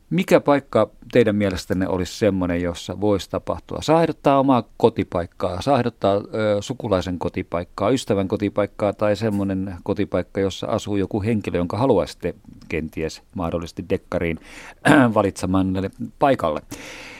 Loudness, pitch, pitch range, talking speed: -21 LUFS, 100 Hz, 90-110 Hz, 110 wpm